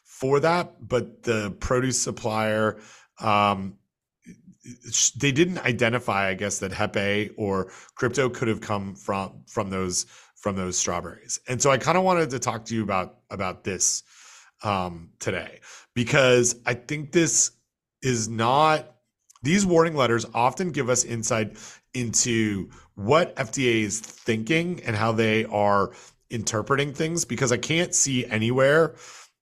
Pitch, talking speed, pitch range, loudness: 120 Hz, 140 wpm, 105-135 Hz, -24 LUFS